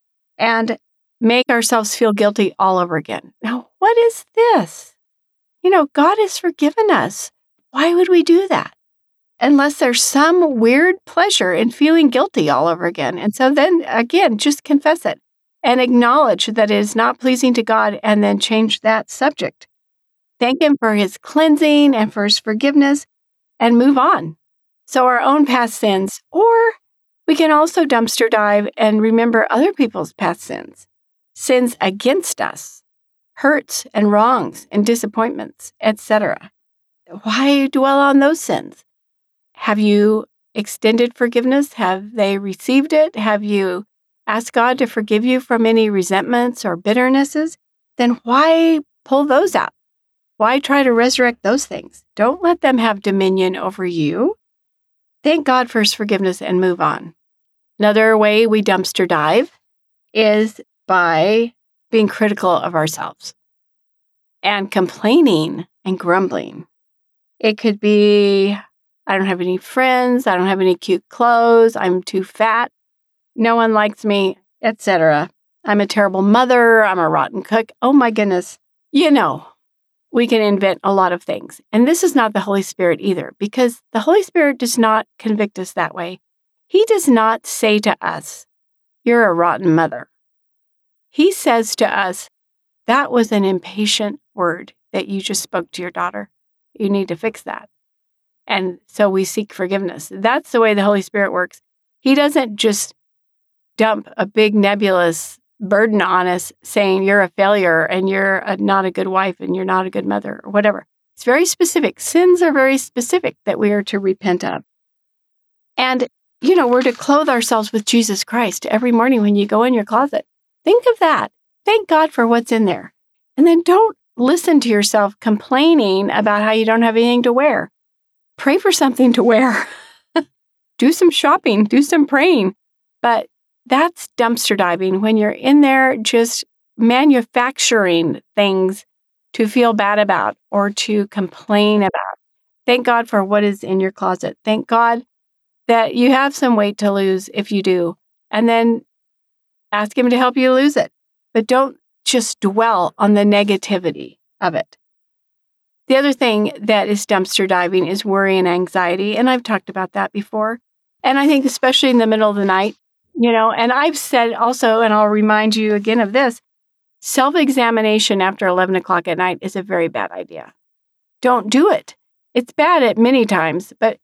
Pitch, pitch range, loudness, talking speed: 225 Hz, 200-265 Hz, -15 LUFS, 165 wpm